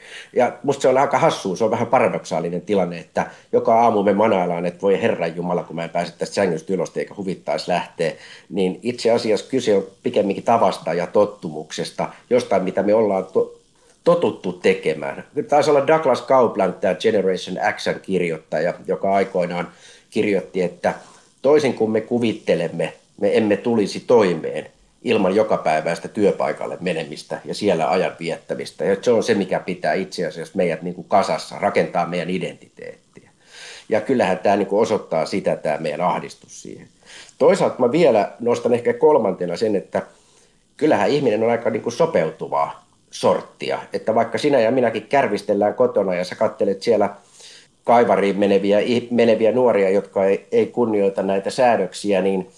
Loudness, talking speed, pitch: -20 LUFS, 155 wpm, 140 Hz